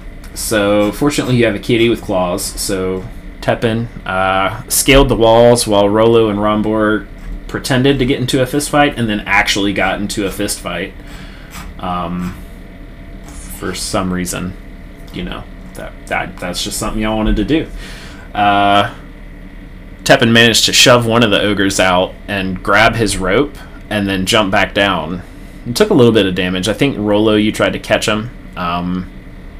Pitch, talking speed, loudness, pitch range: 100 Hz, 165 wpm, -13 LUFS, 95-115 Hz